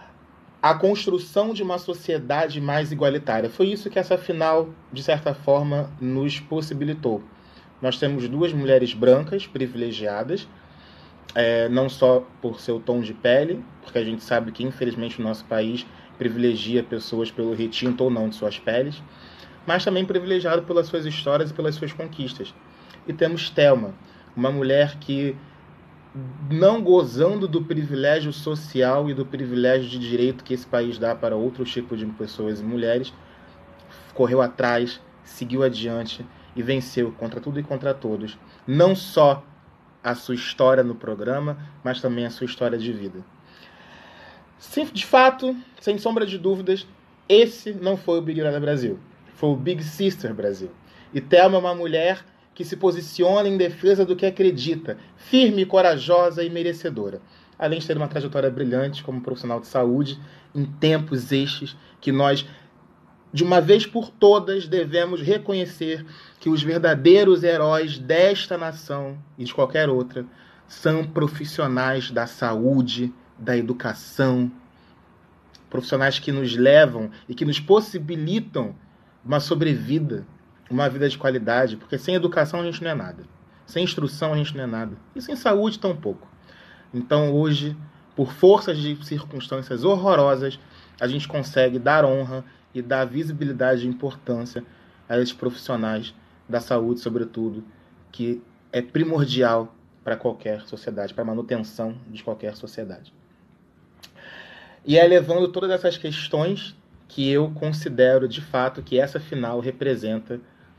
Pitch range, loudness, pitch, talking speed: 120-165 Hz, -22 LUFS, 140 Hz, 145 wpm